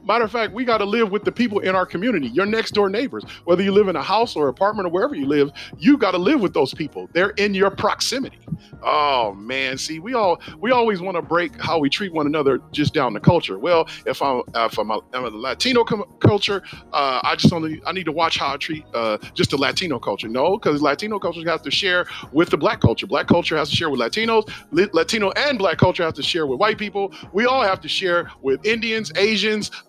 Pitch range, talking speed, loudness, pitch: 160-215 Hz, 245 wpm, -20 LUFS, 190 Hz